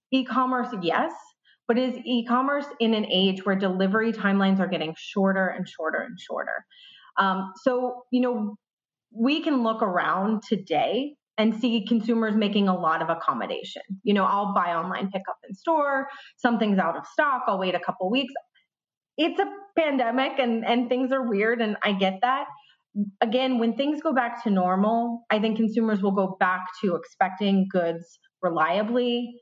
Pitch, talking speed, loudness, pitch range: 220 Hz, 170 wpm, -25 LUFS, 190-255 Hz